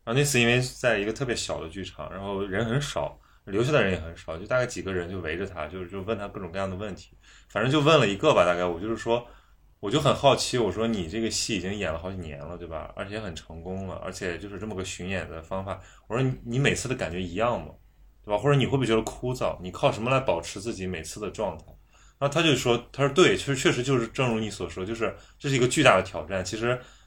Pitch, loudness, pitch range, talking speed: 105 Hz, -26 LUFS, 90-125 Hz, 385 characters per minute